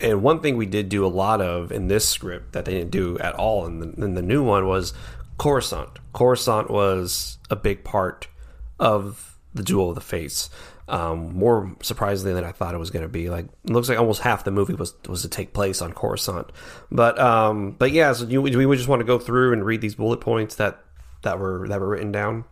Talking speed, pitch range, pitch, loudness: 235 wpm, 90-120 Hz, 105 Hz, -22 LUFS